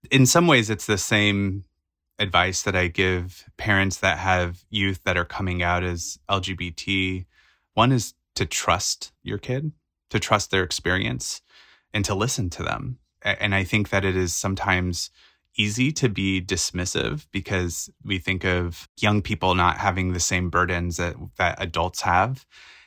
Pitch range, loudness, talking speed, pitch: 90-105 Hz, -23 LUFS, 160 wpm, 95 Hz